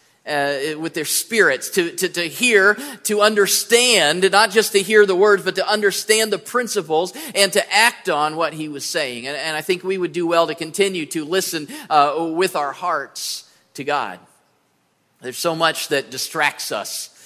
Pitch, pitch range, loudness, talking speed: 190 Hz, 160-210 Hz, -18 LUFS, 185 wpm